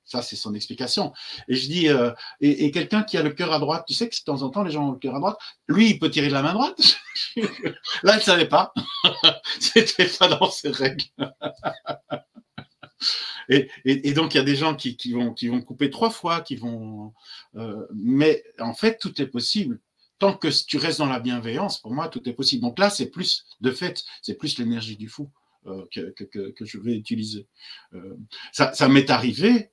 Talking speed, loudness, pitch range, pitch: 225 wpm, -22 LUFS, 120-185 Hz, 145 Hz